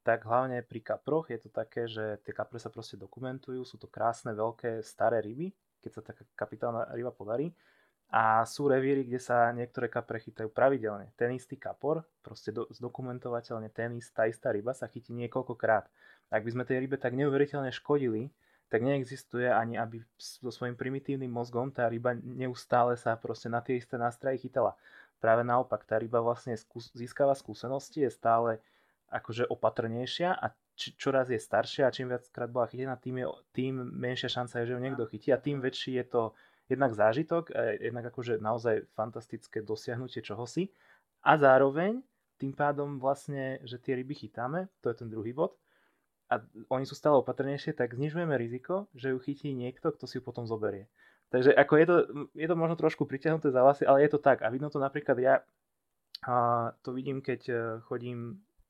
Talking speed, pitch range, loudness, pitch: 180 wpm, 115-135 Hz, -31 LUFS, 125 Hz